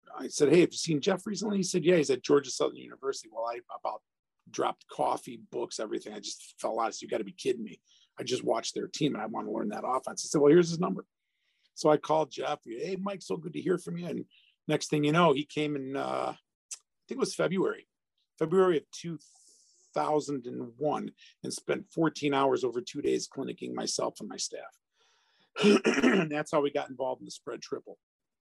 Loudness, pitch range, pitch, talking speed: -30 LUFS, 145-215 Hz, 160 Hz, 220 wpm